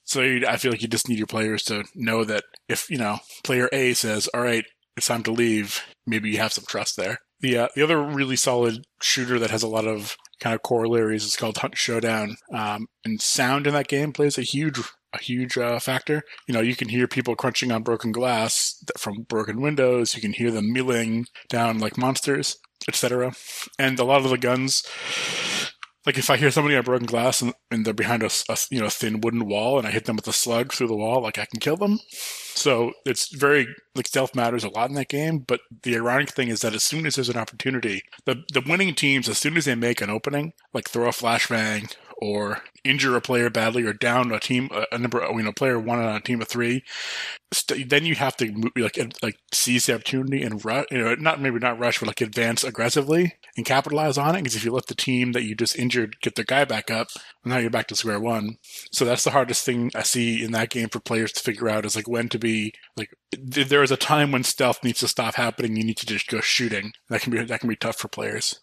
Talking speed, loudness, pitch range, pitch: 240 wpm, -23 LUFS, 115-130 Hz, 120 Hz